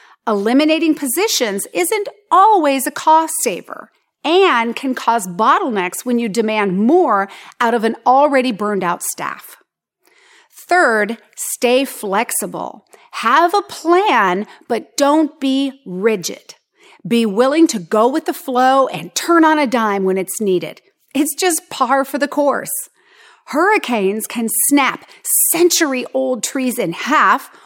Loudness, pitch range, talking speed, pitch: -15 LUFS, 230-335 Hz, 130 wpm, 270 Hz